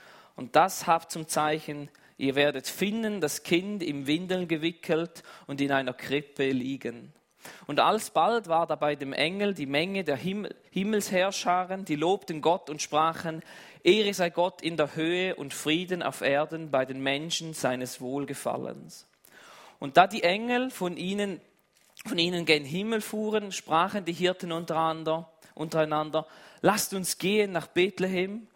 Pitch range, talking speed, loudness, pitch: 150-185 Hz, 150 wpm, -28 LUFS, 165 Hz